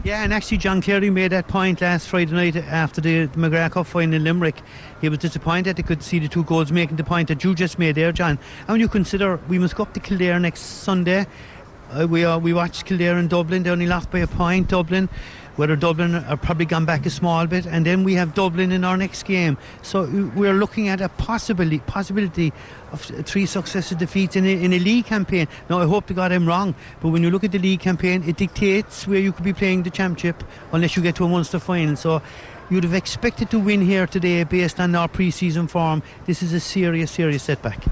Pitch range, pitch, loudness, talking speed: 165-190 Hz, 175 Hz, -20 LUFS, 235 wpm